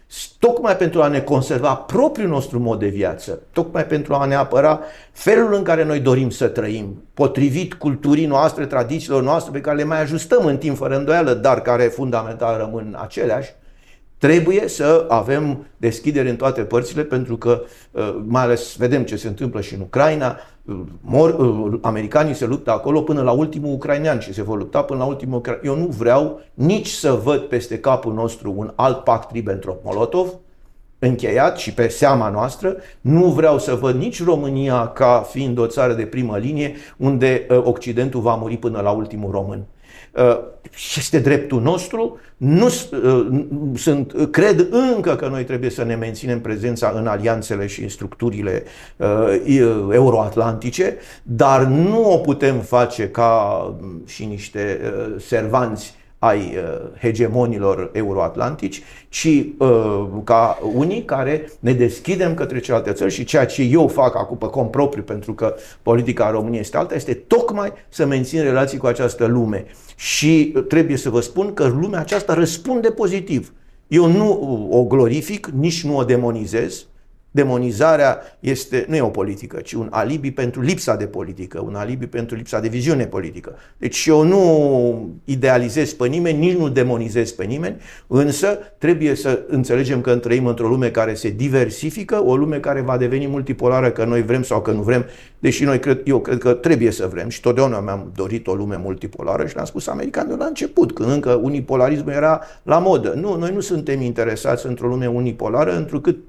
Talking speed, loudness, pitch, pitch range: 165 wpm, -18 LUFS, 125 Hz, 115-150 Hz